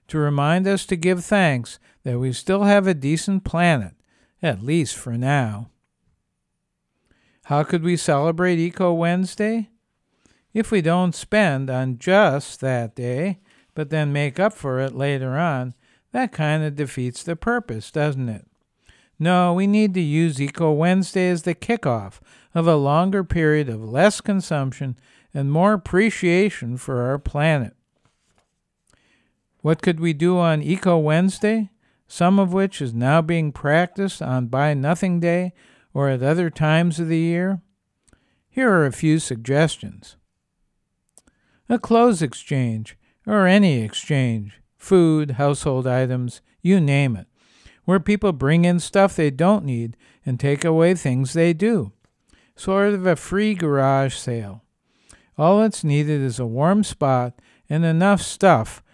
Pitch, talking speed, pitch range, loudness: 160 Hz, 145 wpm, 135-185 Hz, -20 LUFS